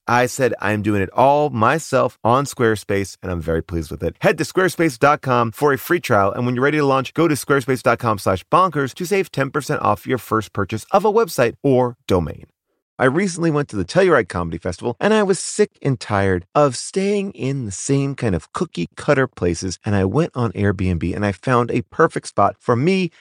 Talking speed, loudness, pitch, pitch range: 210 wpm, -19 LUFS, 125 Hz, 100-150 Hz